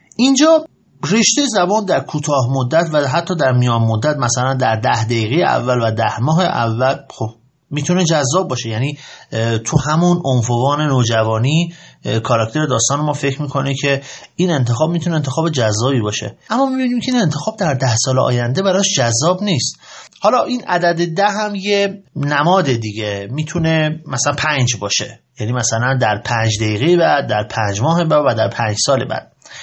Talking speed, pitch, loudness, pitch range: 160 wpm, 140 Hz, -16 LUFS, 120-170 Hz